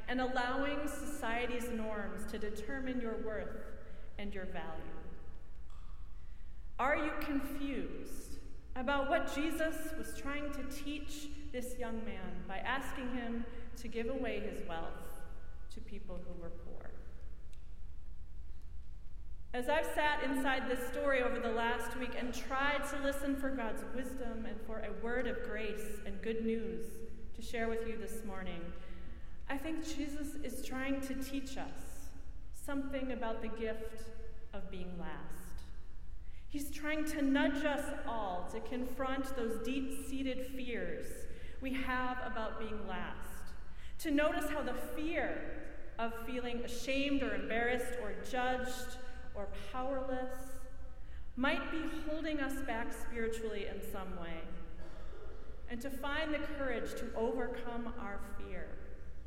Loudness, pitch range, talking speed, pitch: -39 LUFS, 210-275 Hz, 135 wpm, 240 Hz